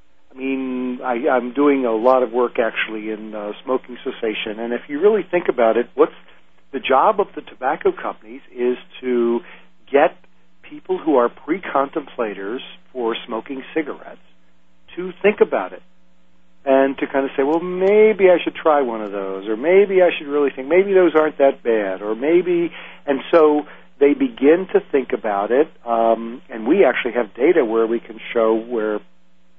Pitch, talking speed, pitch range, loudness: 130 Hz, 175 wpm, 110-160 Hz, -19 LUFS